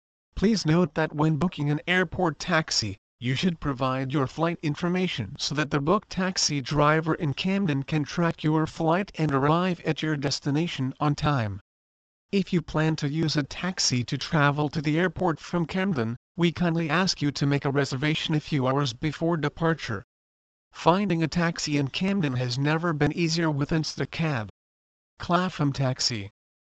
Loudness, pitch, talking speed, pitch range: -26 LUFS, 155 Hz, 165 wpm, 135-170 Hz